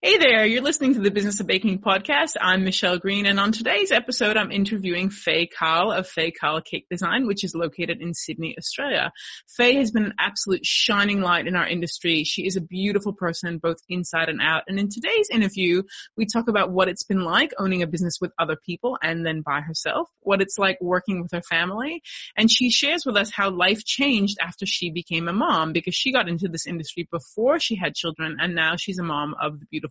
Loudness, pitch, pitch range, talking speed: -22 LUFS, 190 Hz, 170-215 Hz, 220 wpm